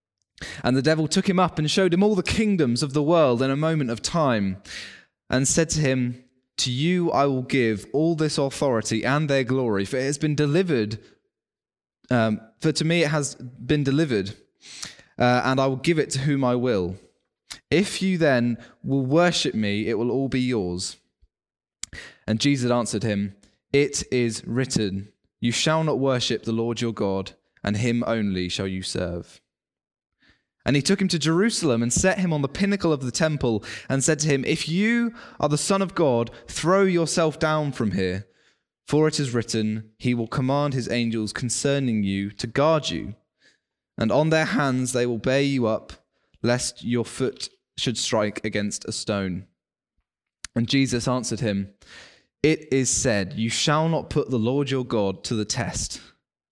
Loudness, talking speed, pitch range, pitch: -23 LUFS, 180 wpm, 110-150 Hz, 130 Hz